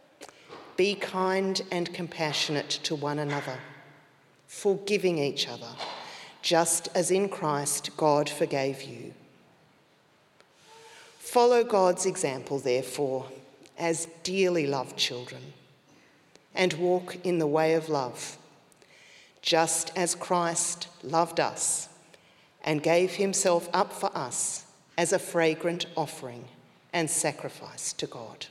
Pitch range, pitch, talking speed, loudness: 145-185 Hz, 165 Hz, 105 wpm, -28 LUFS